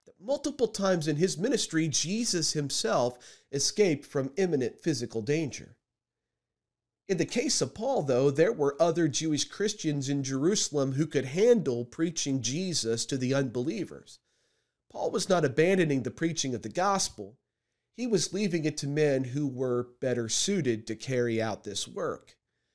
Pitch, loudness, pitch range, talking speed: 145 Hz, -29 LUFS, 130-180 Hz, 150 wpm